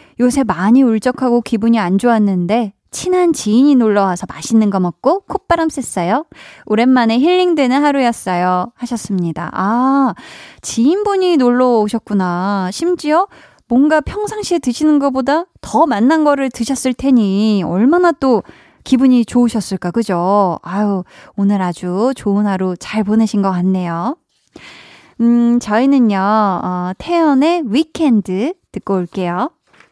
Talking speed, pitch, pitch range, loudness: 280 characters per minute, 235 Hz, 200-275 Hz, -14 LUFS